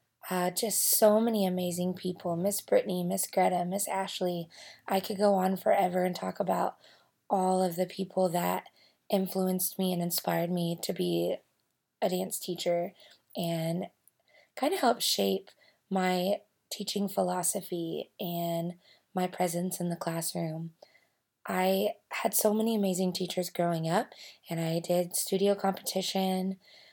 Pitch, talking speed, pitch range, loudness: 185 Hz, 140 wpm, 175-195 Hz, -30 LUFS